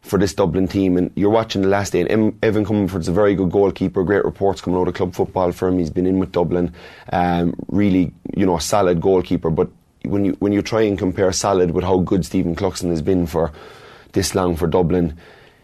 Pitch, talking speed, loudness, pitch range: 95 Hz, 225 wpm, -19 LUFS, 90-100 Hz